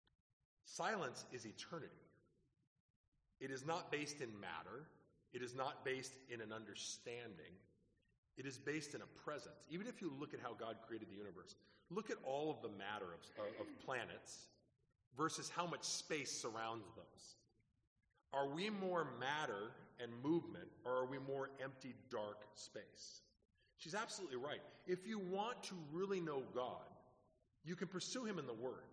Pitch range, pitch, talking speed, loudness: 115-165 Hz, 130 Hz, 160 wpm, -48 LUFS